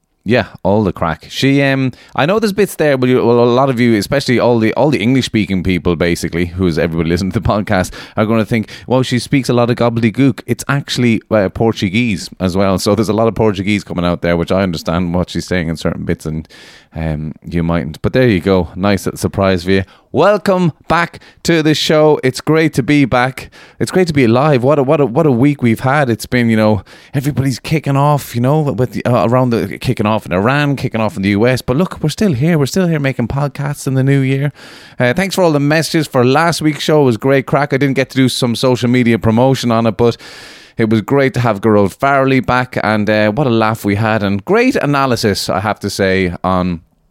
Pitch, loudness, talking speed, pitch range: 120 Hz, -14 LUFS, 240 wpm, 100-140 Hz